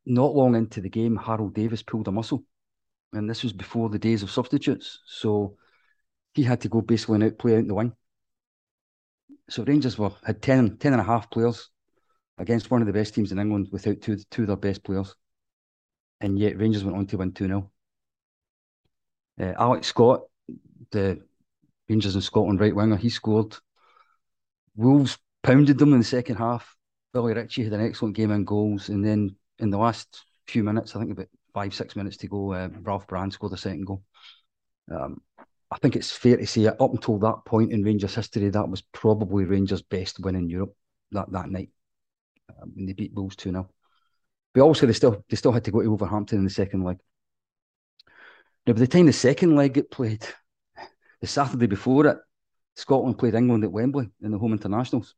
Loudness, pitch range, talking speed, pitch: -24 LUFS, 100-120 Hz, 195 wpm, 110 Hz